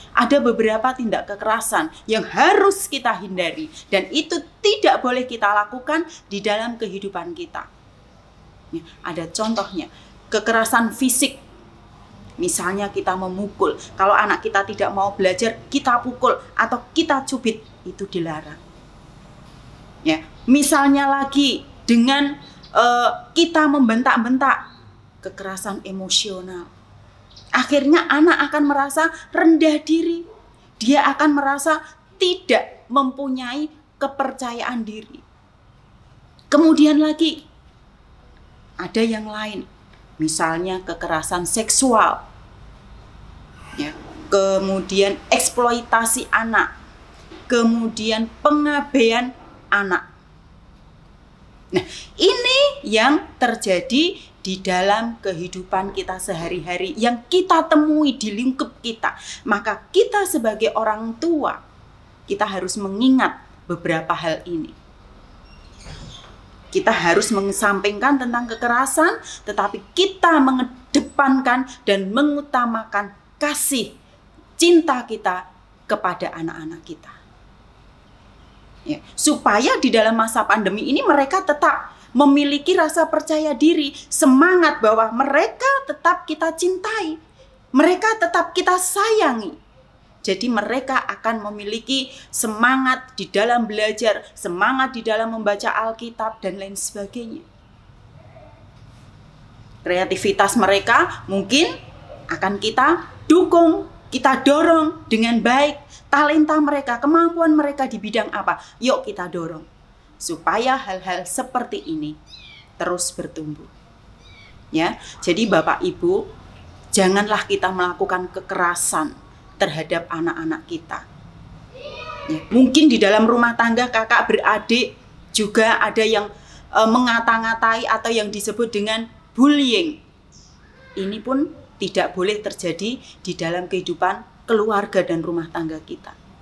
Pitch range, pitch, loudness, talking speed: 195-290 Hz, 230 Hz, -19 LUFS, 100 wpm